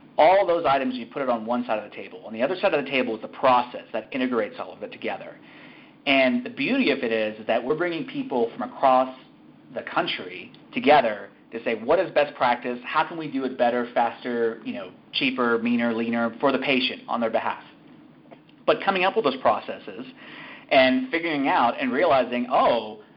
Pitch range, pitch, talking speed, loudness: 120-185 Hz, 130 Hz, 210 wpm, -23 LUFS